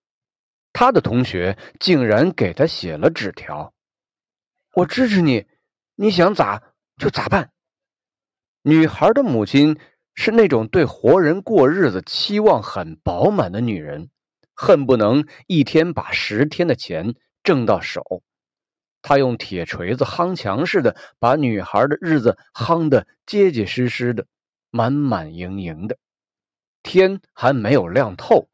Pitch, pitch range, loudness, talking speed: 135 Hz, 105-165 Hz, -18 LUFS, 190 characters per minute